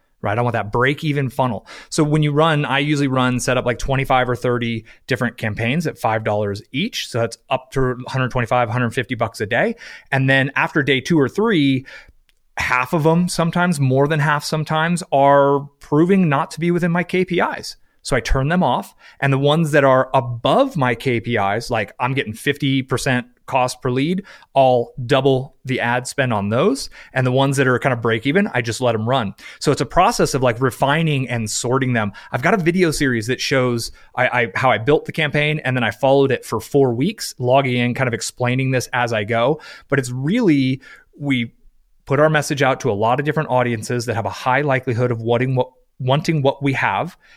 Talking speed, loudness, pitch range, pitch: 210 wpm, -18 LUFS, 125-145 Hz, 130 Hz